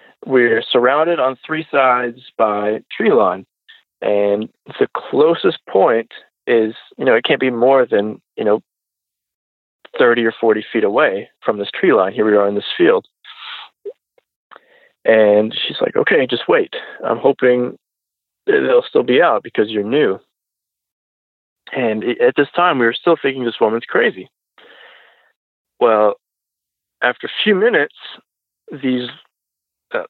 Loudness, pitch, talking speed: -16 LUFS, 125 Hz, 140 wpm